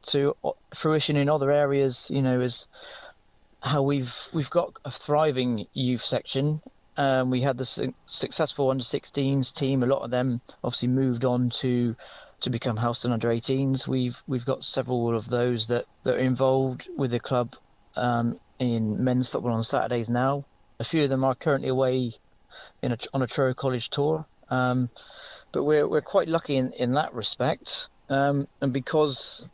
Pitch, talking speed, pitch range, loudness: 130 Hz, 175 wpm, 125-140 Hz, -26 LUFS